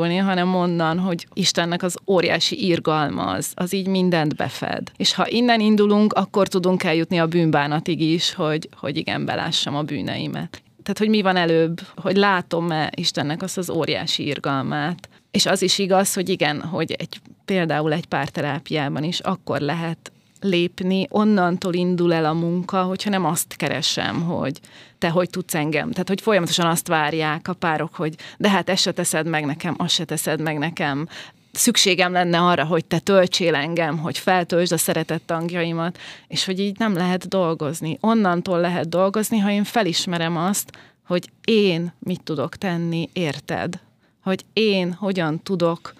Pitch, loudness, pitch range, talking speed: 175 Hz, -21 LUFS, 160-190 Hz, 160 wpm